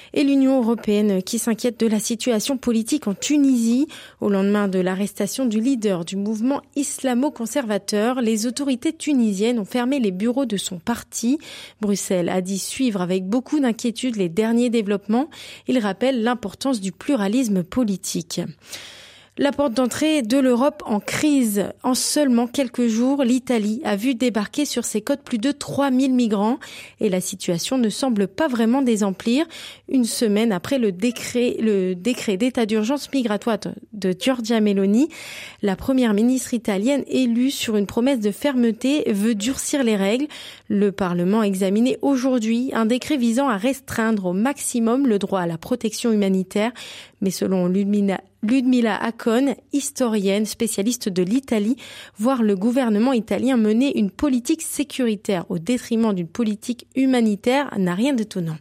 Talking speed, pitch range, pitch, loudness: 150 wpm, 205-260 Hz, 235 Hz, -21 LUFS